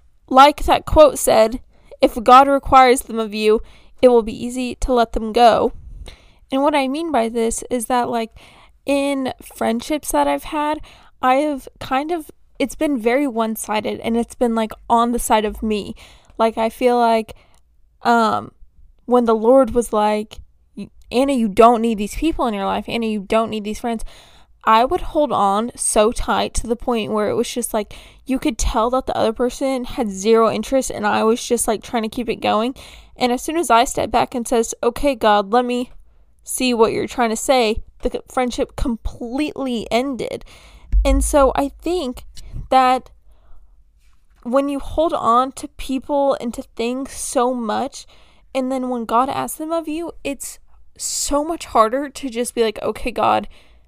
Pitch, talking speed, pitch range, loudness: 245 Hz, 185 wpm, 225-270 Hz, -18 LUFS